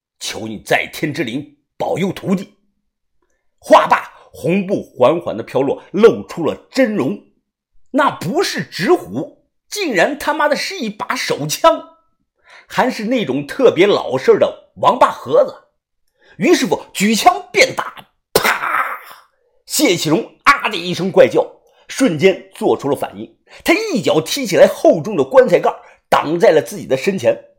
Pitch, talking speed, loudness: 285 Hz, 210 characters per minute, -15 LUFS